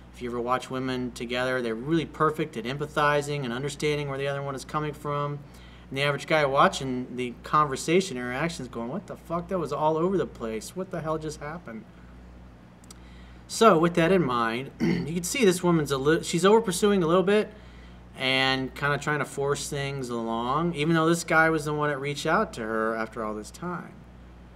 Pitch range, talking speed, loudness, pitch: 120-160 Hz, 205 wpm, -26 LUFS, 145 Hz